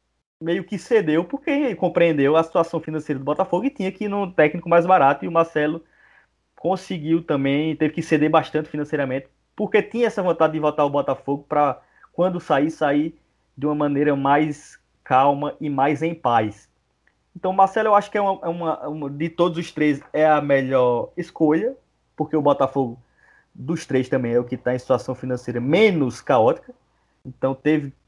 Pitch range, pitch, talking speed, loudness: 140-175 Hz, 155 Hz, 180 wpm, -21 LUFS